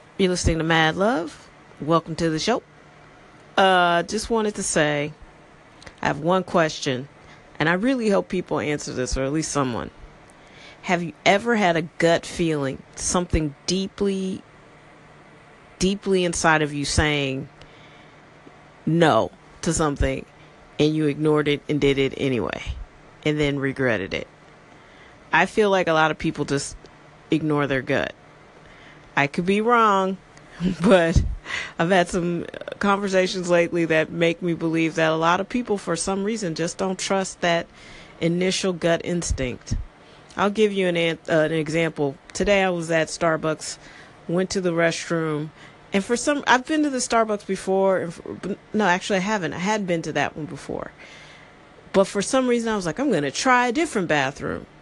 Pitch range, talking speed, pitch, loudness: 150-195 Hz, 165 wpm, 170 Hz, -22 LUFS